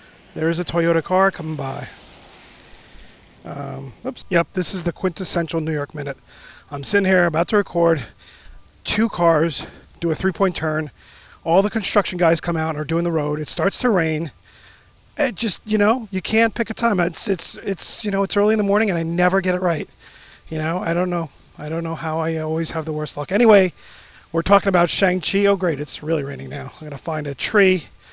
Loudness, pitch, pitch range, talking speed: -20 LUFS, 170 Hz, 155-195 Hz, 215 wpm